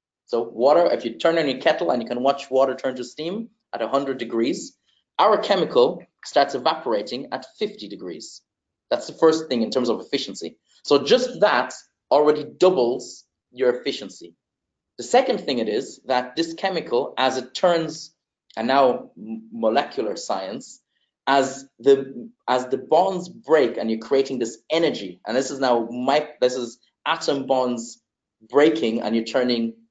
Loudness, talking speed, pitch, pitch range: -22 LUFS, 160 wpm, 135 Hz, 120-160 Hz